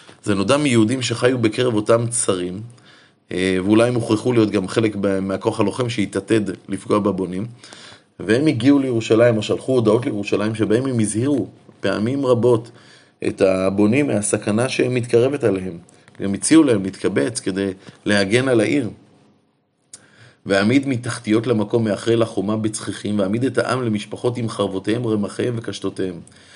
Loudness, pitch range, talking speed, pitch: -19 LUFS, 100-120 Hz, 130 wpm, 110 Hz